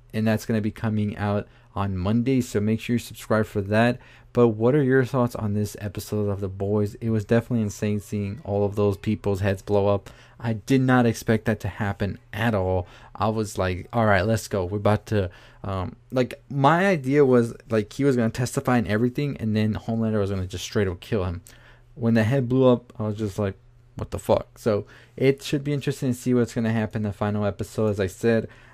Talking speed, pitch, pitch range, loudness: 235 wpm, 110 Hz, 105-120 Hz, -24 LUFS